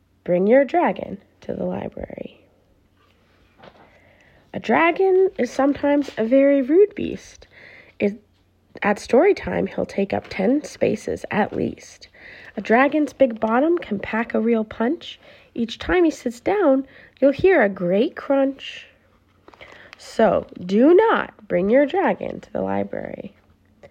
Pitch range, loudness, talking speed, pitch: 220-310 Hz, -20 LUFS, 135 wpm, 270 Hz